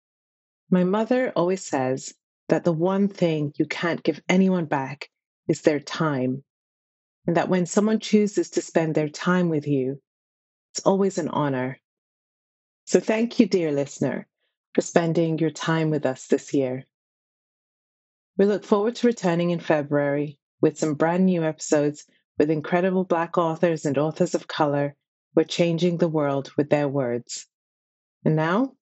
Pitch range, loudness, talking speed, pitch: 145-180 Hz, -23 LUFS, 155 wpm, 160 Hz